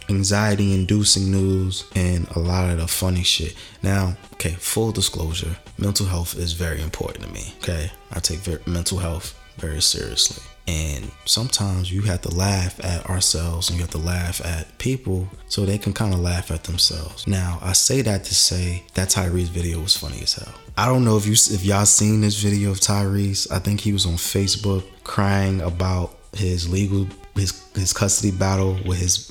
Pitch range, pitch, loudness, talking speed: 85-100 Hz, 95 Hz, -21 LUFS, 185 wpm